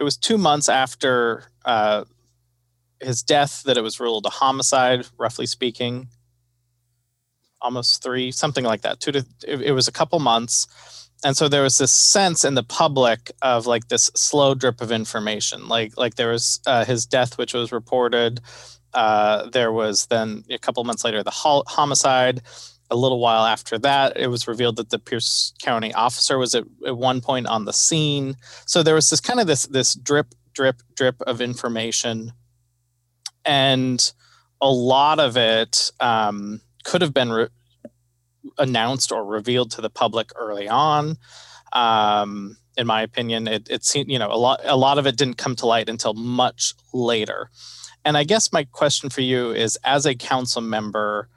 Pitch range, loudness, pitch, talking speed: 115-135 Hz, -20 LUFS, 120 Hz, 180 wpm